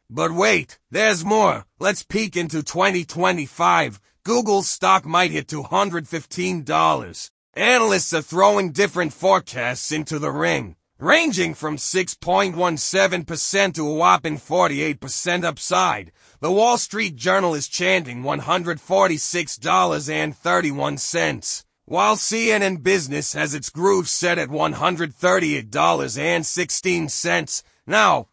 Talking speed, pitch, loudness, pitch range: 100 wpm, 175 Hz, -20 LUFS, 155-195 Hz